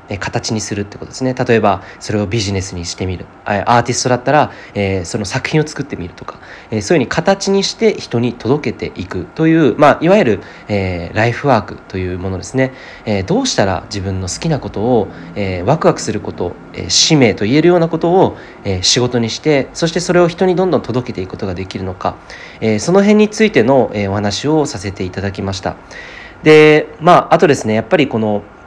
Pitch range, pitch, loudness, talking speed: 100-150 Hz, 115 Hz, -14 LUFS, 400 characters per minute